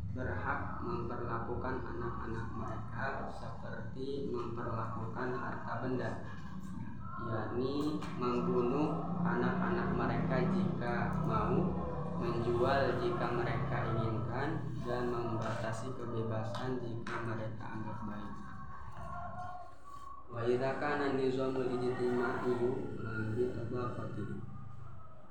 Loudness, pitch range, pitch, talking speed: -37 LUFS, 115-140 Hz, 120 Hz, 65 wpm